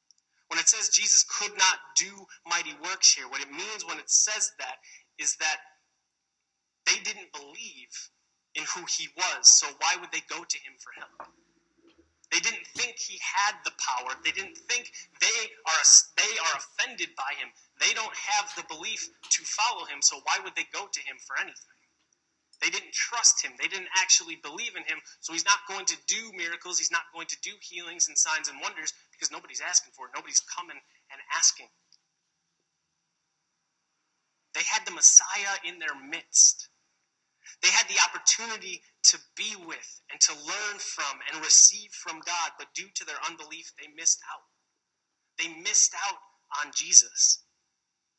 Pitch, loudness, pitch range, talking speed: 175 Hz, -24 LUFS, 160-205 Hz, 175 wpm